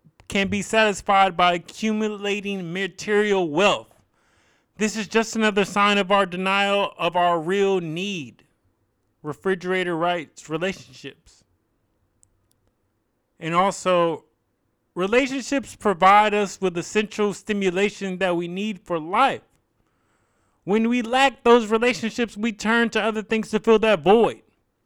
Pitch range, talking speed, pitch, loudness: 160-215 Hz, 120 wpm, 195 Hz, -21 LUFS